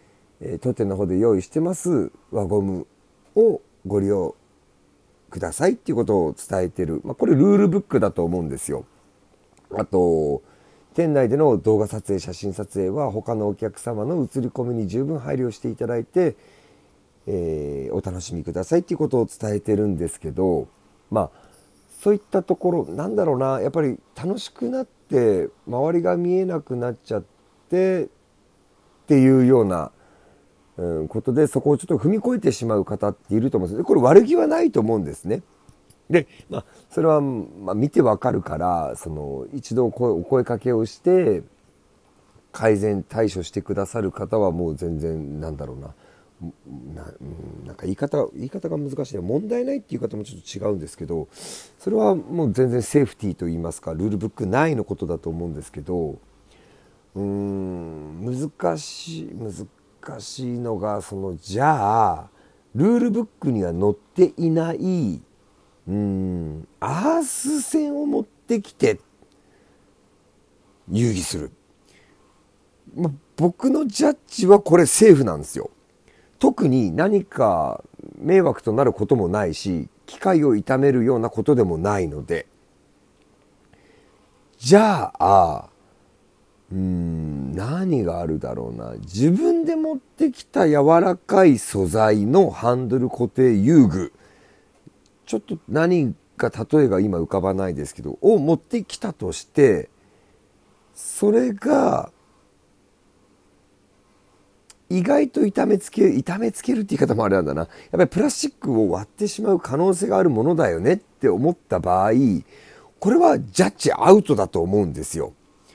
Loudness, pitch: -21 LUFS, 110 Hz